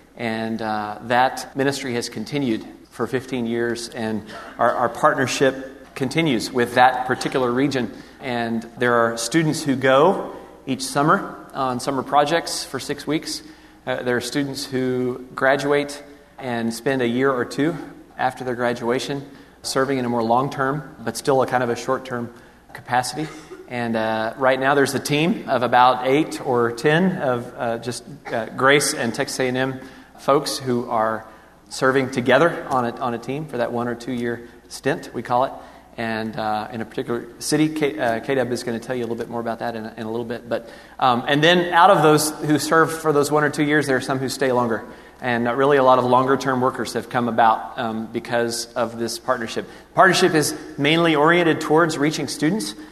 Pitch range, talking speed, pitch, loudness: 120-145 Hz, 195 wpm, 130 Hz, -21 LUFS